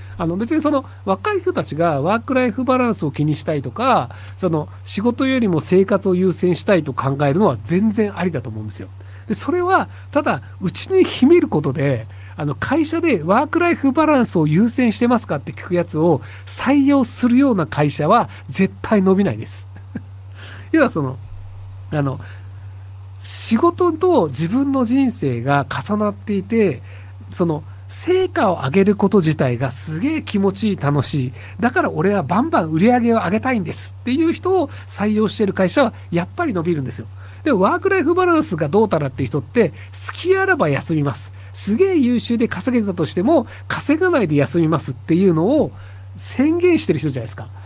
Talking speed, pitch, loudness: 365 characters per minute, 175 Hz, -18 LUFS